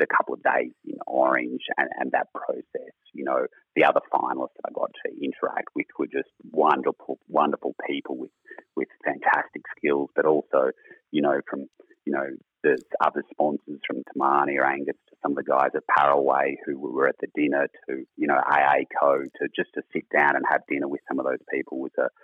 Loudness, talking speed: -25 LUFS, 205 wpm